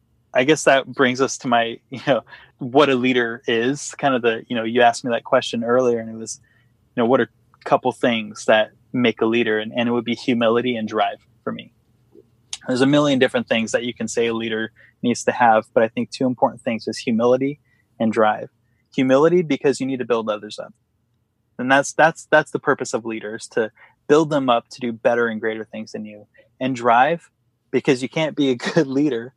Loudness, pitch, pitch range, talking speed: -20 LUFS, 120 Hz, 115-135 Hz, 225 wpm